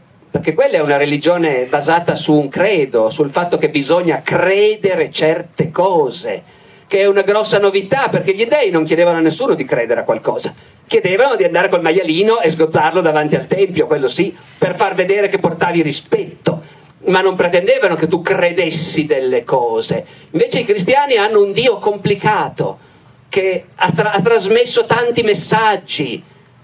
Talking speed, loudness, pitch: 160 wpm, -14 LUFS, 195 Hz